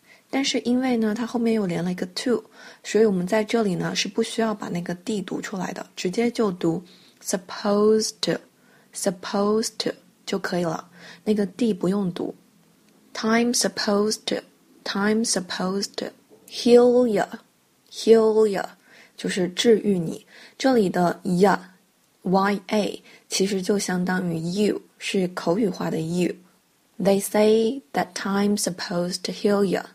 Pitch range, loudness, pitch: 190-225 Hz, -23 LUFS, 210 Hz